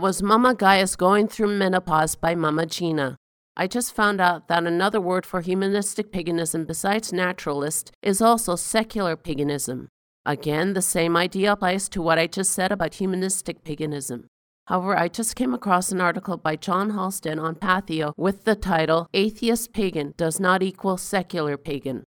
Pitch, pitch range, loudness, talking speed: 180 Hz, 160-195 Hz, -23 LUFS, 165 wpm